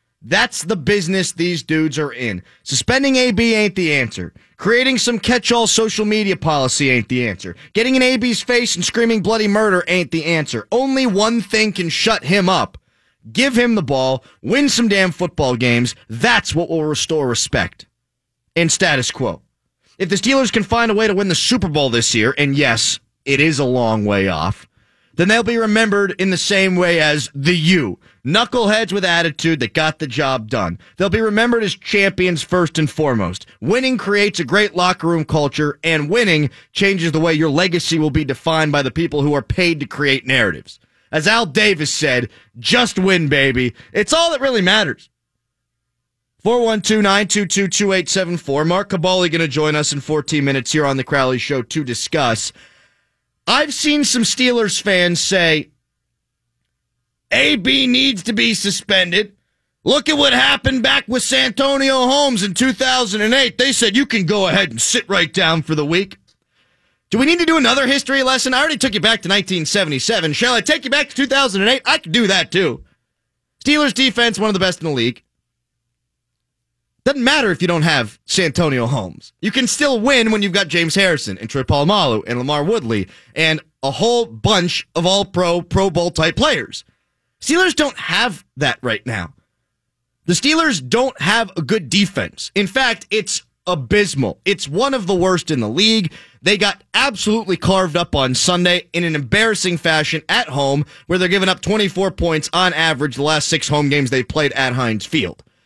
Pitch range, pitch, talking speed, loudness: 145-225 Hz, 180 Hz, 180 wpm, -16 LUFS